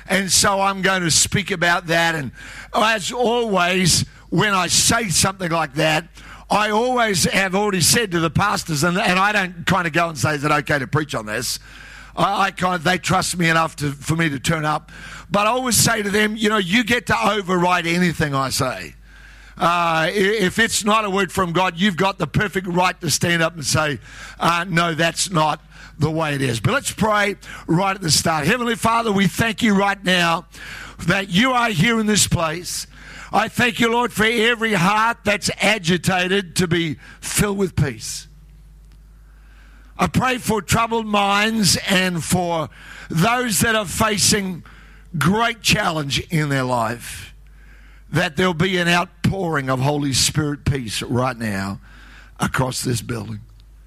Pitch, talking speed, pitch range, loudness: 180 Hz, 180 wpm, 155-205 Hz, -18 LUFS